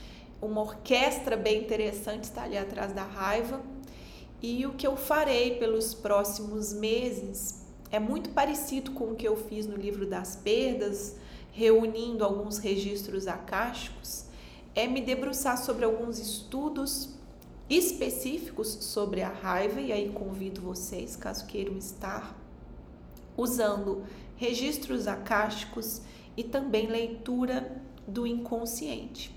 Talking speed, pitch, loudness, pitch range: 120 wpm, 220 Hz, -31 LUFS, 205-250 Hz